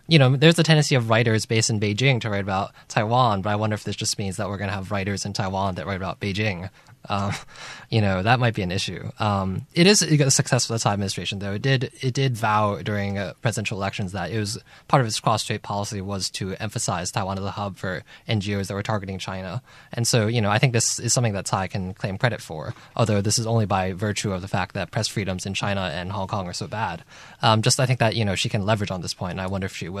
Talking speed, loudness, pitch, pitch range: 270 wpm, -23 LUFS, 105 Hz, 100-120 Hz